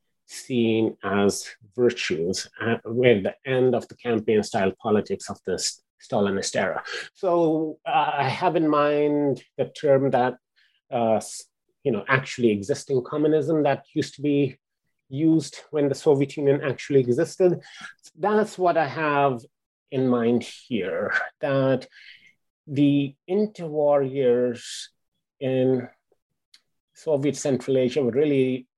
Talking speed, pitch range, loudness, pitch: 125 wpm, 125-155 Hz, -24 LUFS, 140 Hz